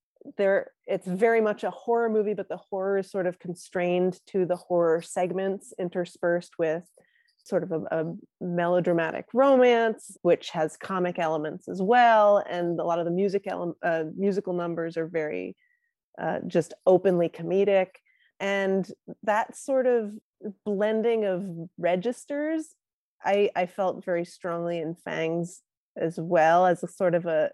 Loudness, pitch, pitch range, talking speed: -26 LUFS, 185 Hz, 170-210 Hz, 150 wpm